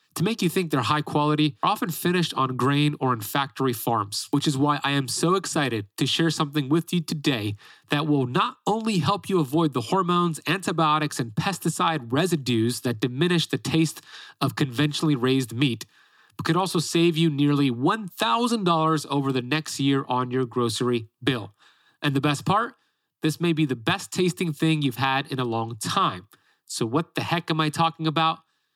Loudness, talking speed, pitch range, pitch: -24 LUFS, 185 wpm, 135-170 Hz, 150 Hz